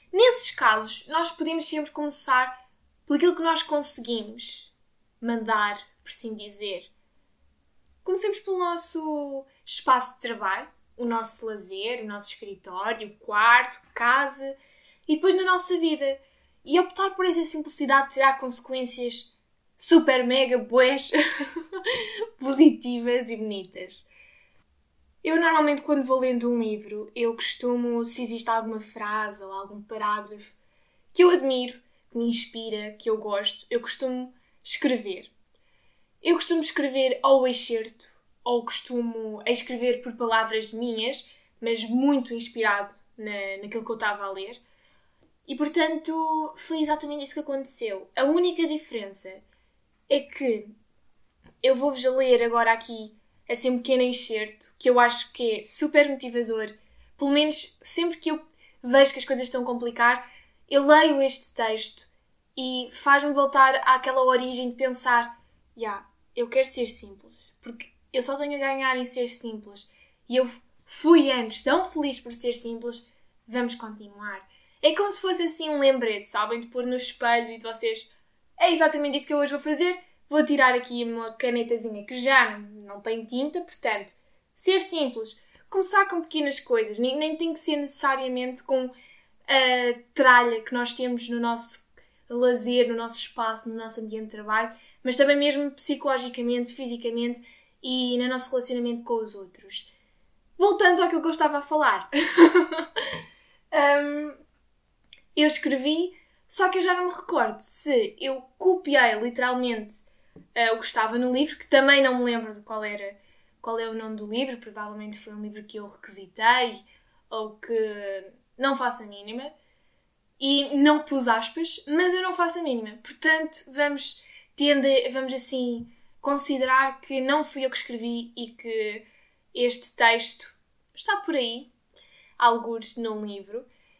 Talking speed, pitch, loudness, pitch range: 150 wpm, 250 Hz, -25 LUFS, 230-290 Hz